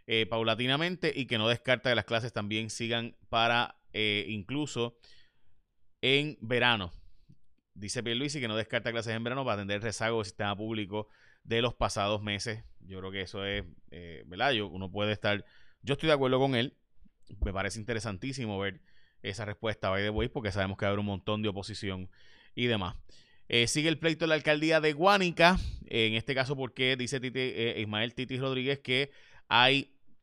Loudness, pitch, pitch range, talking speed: -30 LUFS, 115 Hz, 105-130 Hz, 195 wpm